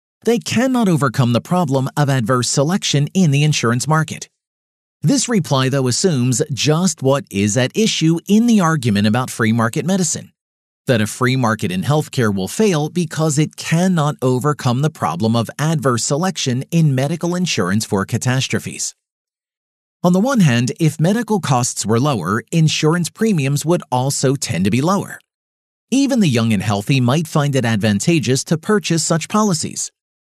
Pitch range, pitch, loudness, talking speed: 125-180 Hz, 150 Hz, -17 LUFS, 160 wpm